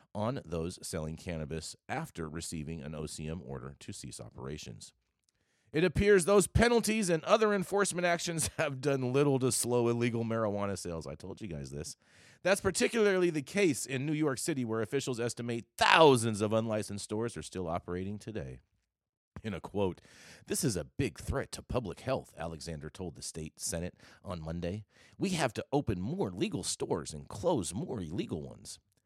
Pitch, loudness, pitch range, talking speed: 105 Hz, -32 LUFS, 80-140 Hz, 170 wpm